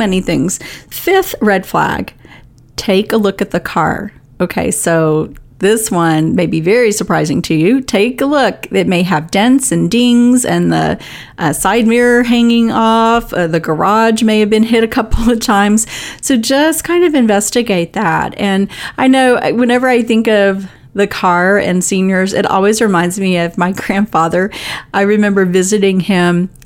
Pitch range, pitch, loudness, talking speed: 180-235 Hz, 205 Hz, -12 LUFS, 170 wpm